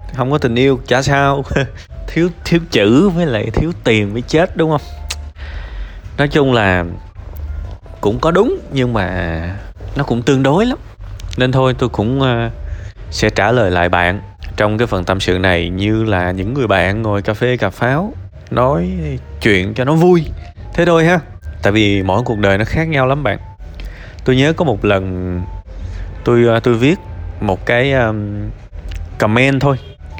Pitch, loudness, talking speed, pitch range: 105 Hz, -15 LUFS, 170 wpm, 90-130 Hz